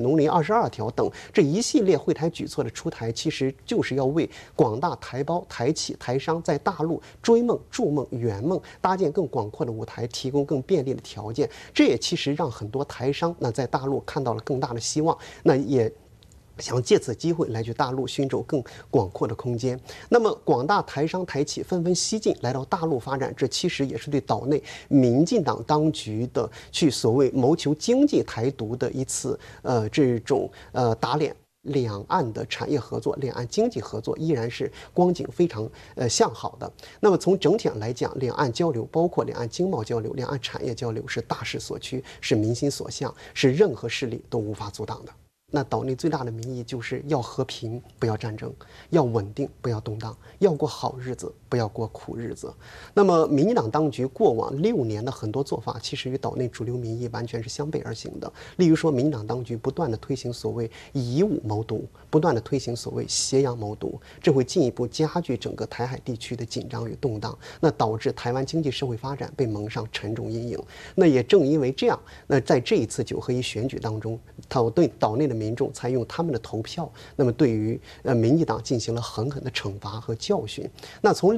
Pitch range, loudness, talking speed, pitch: 115-150 Hz, -25 LUFS, 300 characters per minute, 130 Hz